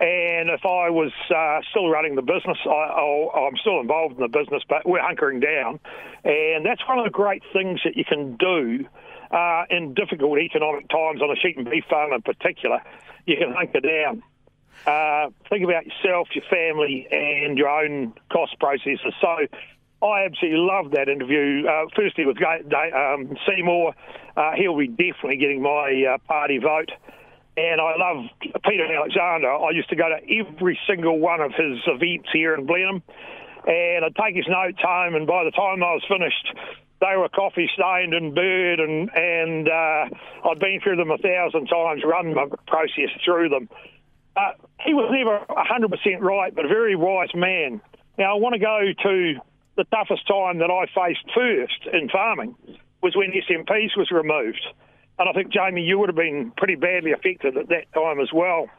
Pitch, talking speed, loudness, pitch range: 175 Hz, 185 wpm, -21 LUFS, 160-195 Hz